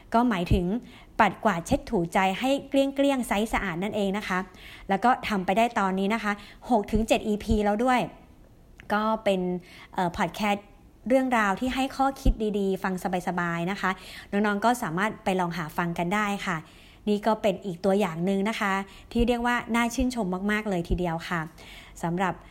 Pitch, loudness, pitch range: 205 Hz, -26 LUFS, 185-230 Hz